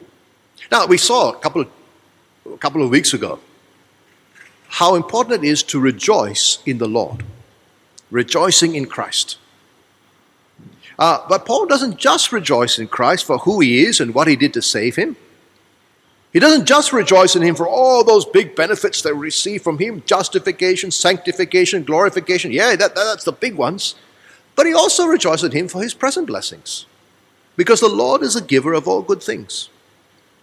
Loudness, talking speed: -15 LUFS, 170 wpm